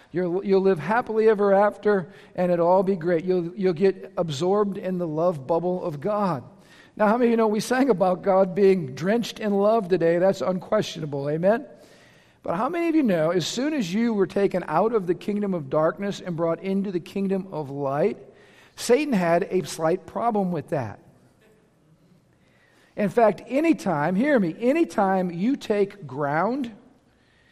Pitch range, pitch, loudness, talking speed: 175-215 Hz, 195 Hz, -23 LUFS, 170 wpm